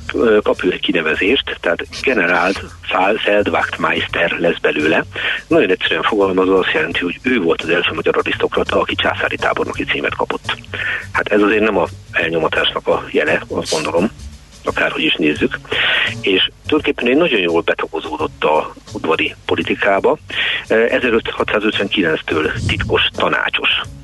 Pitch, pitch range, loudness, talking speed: 95 Hz, 85-125 Hz, -16 LUFS, 125 wpm